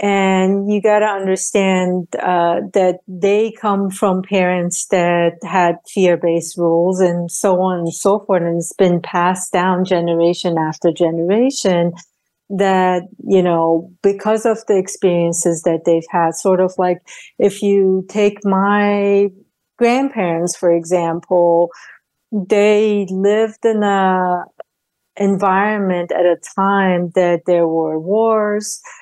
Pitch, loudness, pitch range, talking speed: 185 Hz, -16 LUFS, 175-200 Hz, 125 wpm